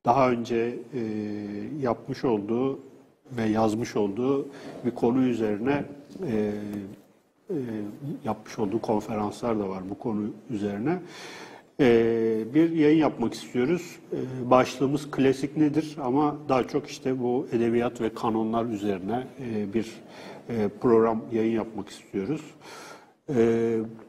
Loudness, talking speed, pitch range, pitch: -27 LUFS, 115 wpm, 110-130 Hz, 115 Hz